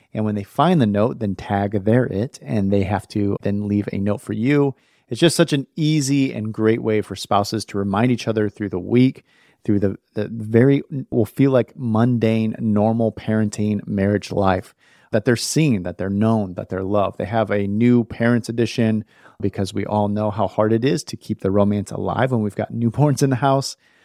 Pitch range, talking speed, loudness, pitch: 100-120 Hz, 210 wpm, -20 LUFS, 110 Hz